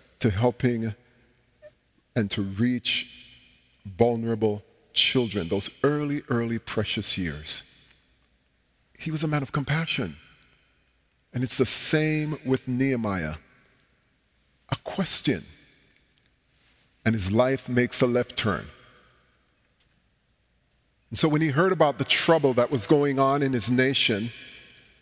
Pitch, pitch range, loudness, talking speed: 120 Hz, 105-135 Hz, -24 LUFS, 115 wpm